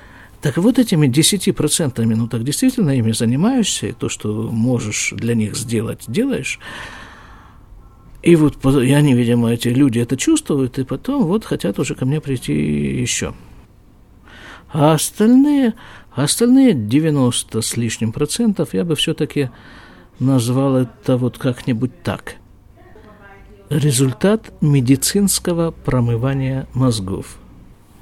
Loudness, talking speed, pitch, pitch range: -17 LUFS, 115 wpm, 130 Hz, 115-155 Hz